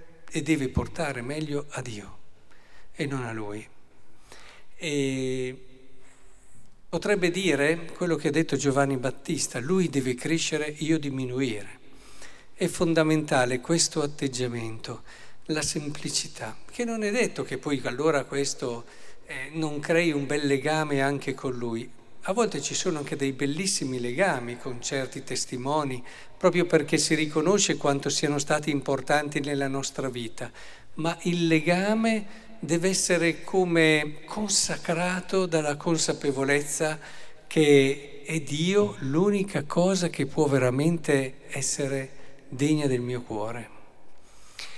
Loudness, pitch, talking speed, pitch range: -26 LUFS, 145 Hz, 120 wpm, 135-165 Hz